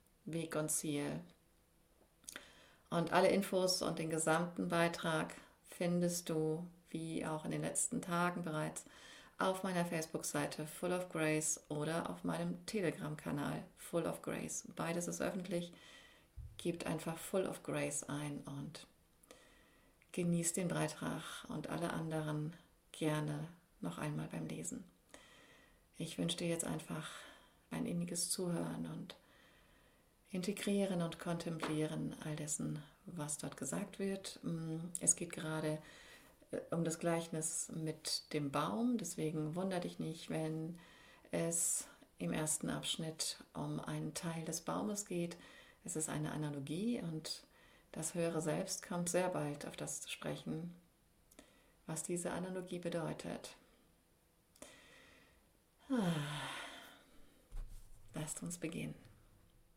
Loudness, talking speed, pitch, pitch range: -40 LUFS, 115 wpm, 160 Hz, 150-175 Hz